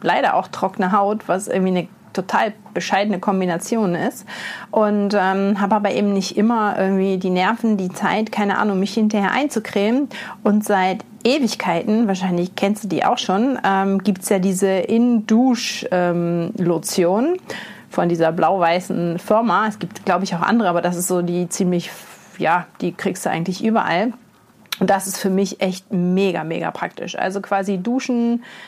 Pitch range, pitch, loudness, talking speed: 185-220 Hz, 195 Hz, -19 LUFS, 165 wpm